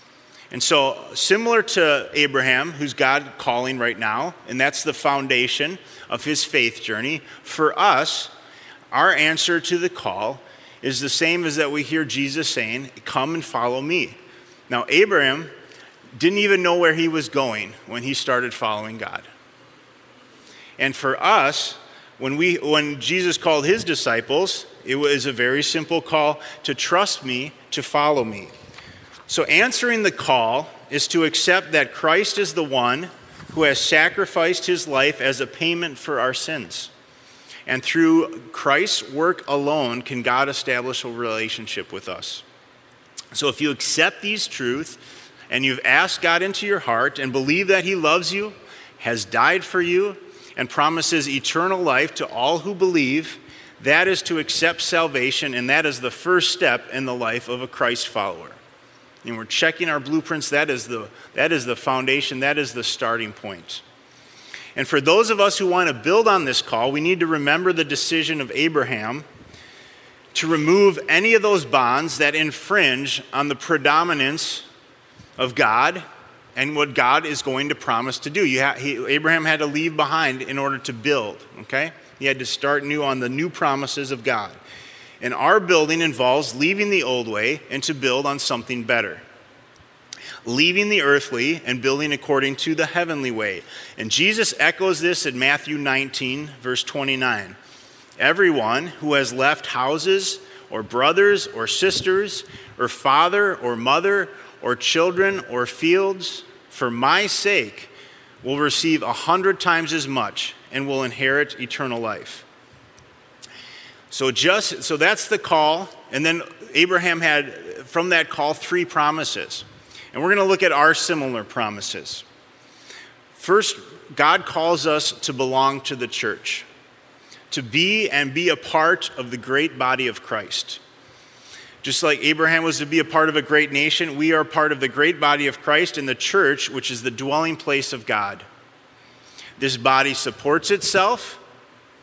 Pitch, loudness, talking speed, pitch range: 150 Hz, -20 LUFS, 165 wpm, 135-170 Hz